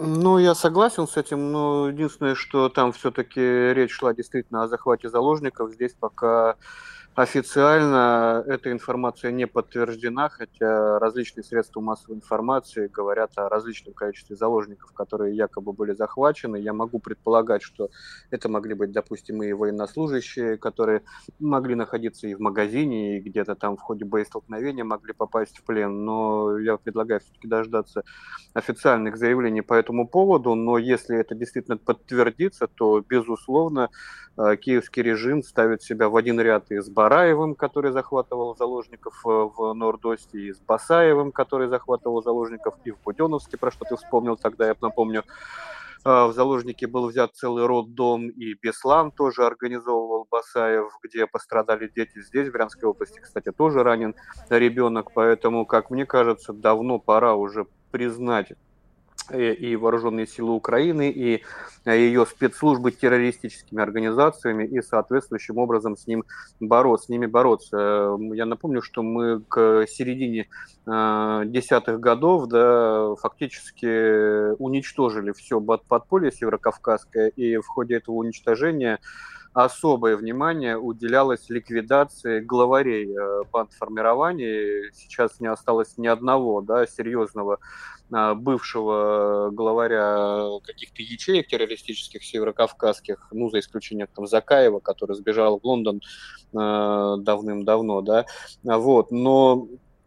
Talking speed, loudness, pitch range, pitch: 125 wpm, -23 LUFS, 110-125 Hz, 115 Hz